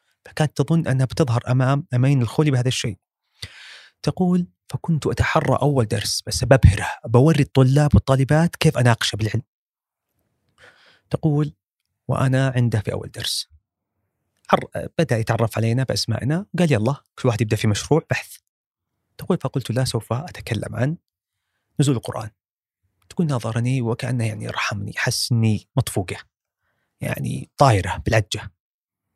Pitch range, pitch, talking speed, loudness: 110-140 Hz, 120 Hz, 120 wpm, -21 LUFS